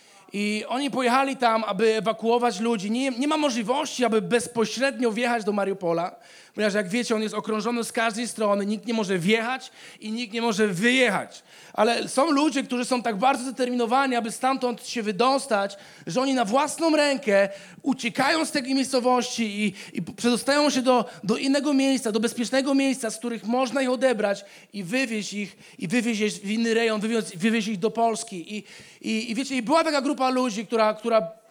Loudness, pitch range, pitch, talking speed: -24 LUFS, 215-260 Hz, 235 Hz, 185 wpm